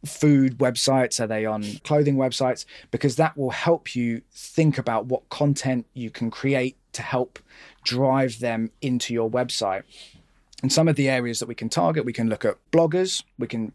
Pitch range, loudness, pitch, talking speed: 120-140 Hz, -24 LUFS, 130 Hz, 185 wpm